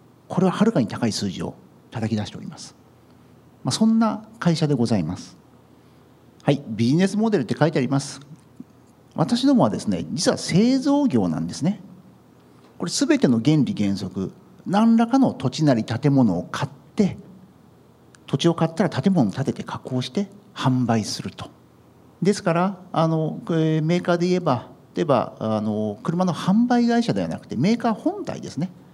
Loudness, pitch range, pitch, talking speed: -22 LUFS, 125-205 Hz, 165 Hz, 320 characters per minute